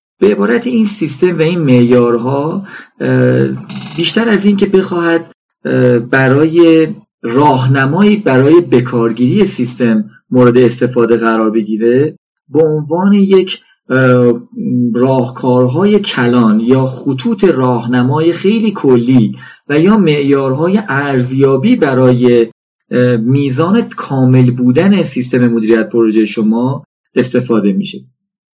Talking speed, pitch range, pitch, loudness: 95 wpm, 125-175 Hz, 130 Hz, -11 LUFS